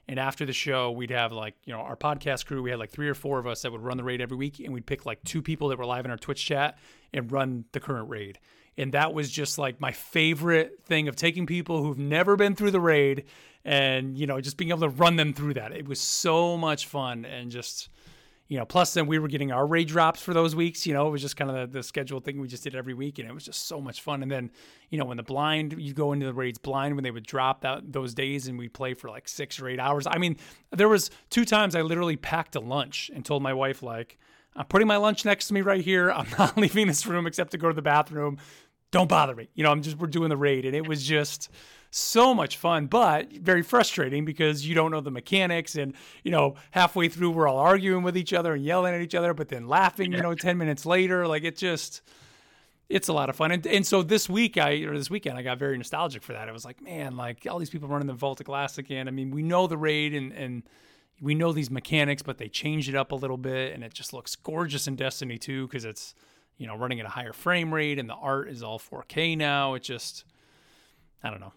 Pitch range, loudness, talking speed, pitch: 130-165 Hz, -27 LUFS, 265 wpm, 145 Hz